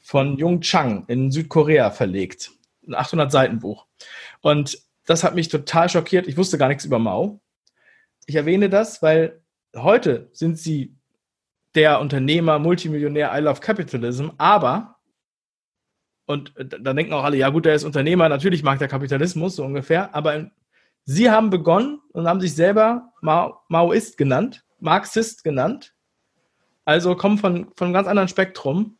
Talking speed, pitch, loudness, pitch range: 150 wpm, 160 Hz, -20 LUFS, 145-185 Hz